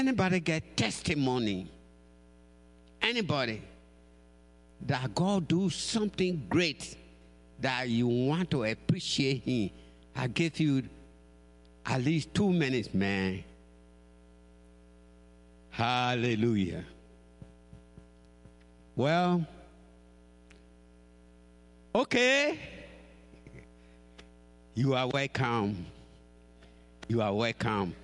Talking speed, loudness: 70 wpm, -30 LUFS